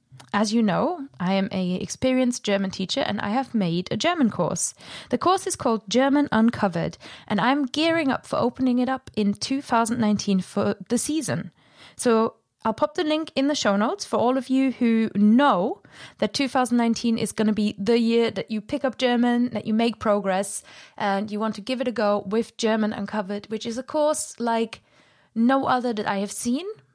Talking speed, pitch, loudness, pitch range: 200 wpm, 230 Hz, -23 LUFS, 210-260 Hz